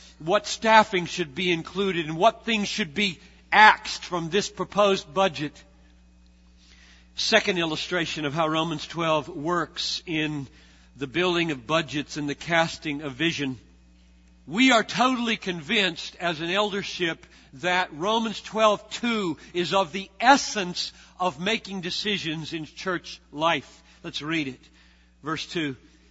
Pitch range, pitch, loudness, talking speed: 150-200 Hz, 170 Hz, -24 LUFS, 130 wpm